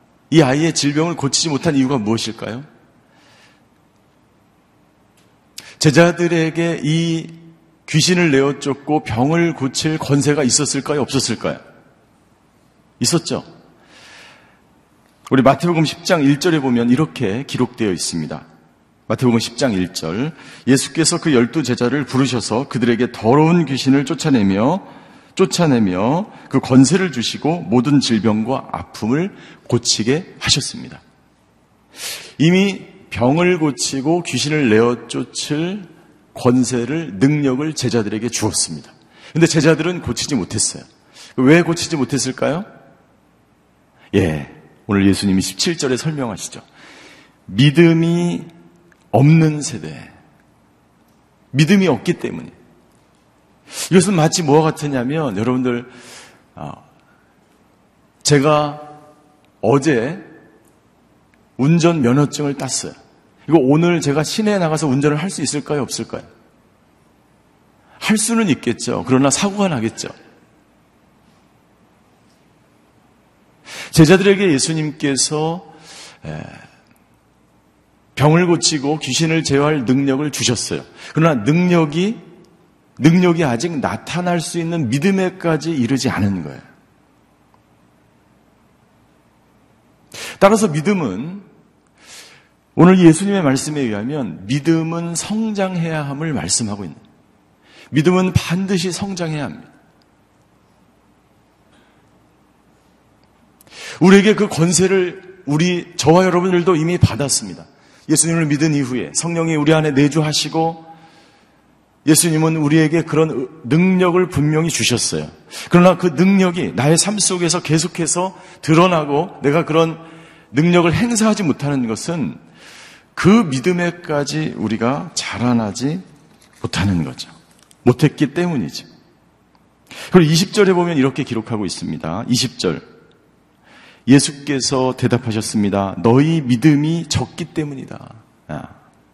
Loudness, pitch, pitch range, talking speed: -16 LUFS, 150 Hz, 120-170 Hz, 240 characters per minute